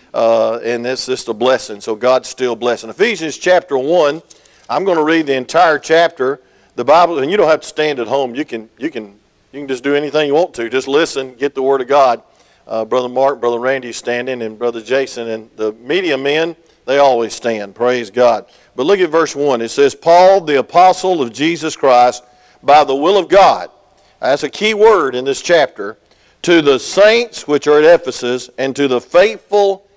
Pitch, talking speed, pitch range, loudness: 135 Hz, 205 wpm, 120-155 Hz, -14 LUFS